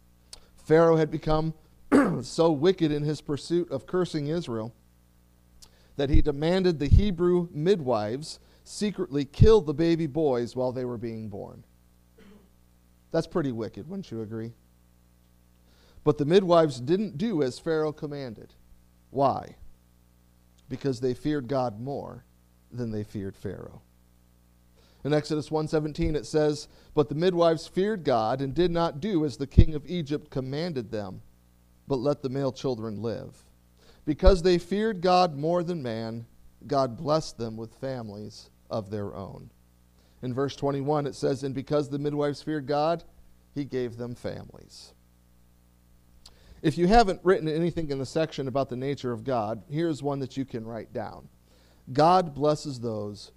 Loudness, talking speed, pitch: -27 LUFS, 145 wpm, 135 Hz